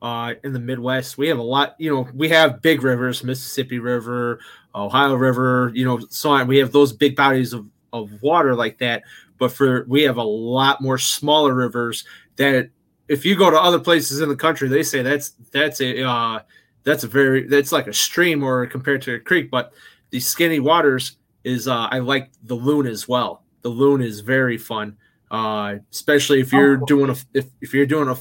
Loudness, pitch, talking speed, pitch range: -19 LUFS, 130 Hz, 205 wpm, 120-145 Hz